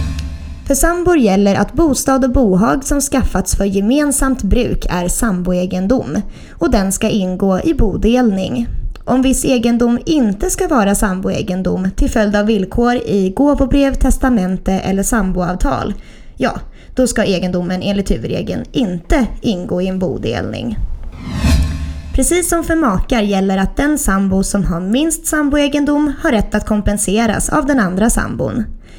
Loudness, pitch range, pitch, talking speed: -15 LUFS, 185-265 Hz, 210 Hz, 140 wpm